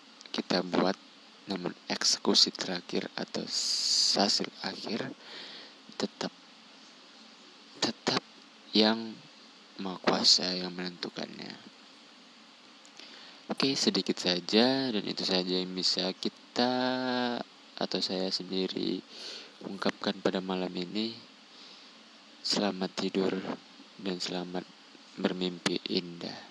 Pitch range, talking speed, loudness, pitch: 90-135 Hz, 85 wpm, -30 LUFS, 100 Hz